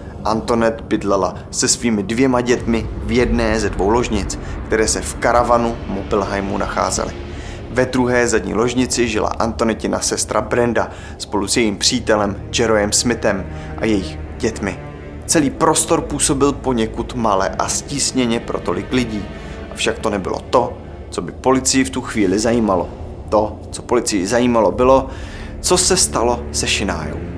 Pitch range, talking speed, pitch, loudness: 95-120 Hz, 140 wpm, 110 Hz, -17 LUFS